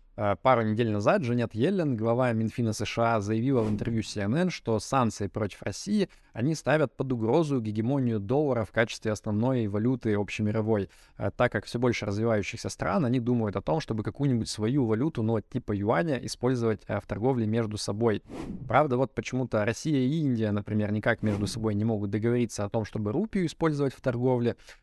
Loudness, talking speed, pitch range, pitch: -28 LUFS, 165 wpm, 105-130 Hz, 115 Hz